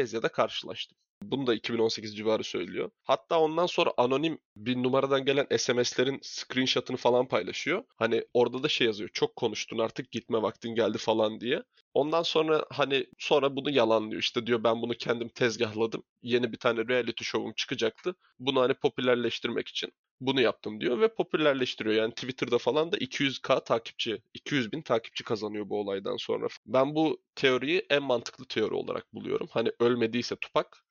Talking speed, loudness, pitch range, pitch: 160 wpm, -29 LUFS, 115-140 Hz, 125 Hz